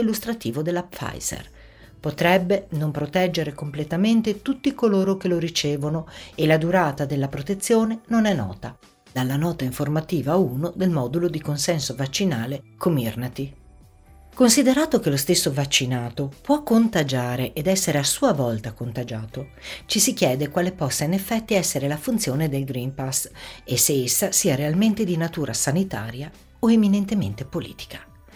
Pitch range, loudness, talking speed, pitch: 130-190 Hz, -22 LUFS, 140 wpm, 155 Hz